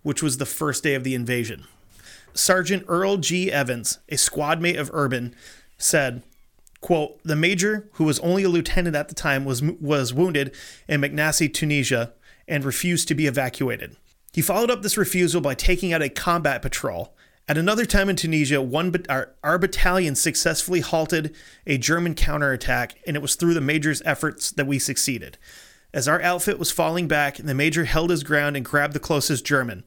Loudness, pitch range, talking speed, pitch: -22 LUFS, 140-175 Hz, 185 wpm, 155 Hz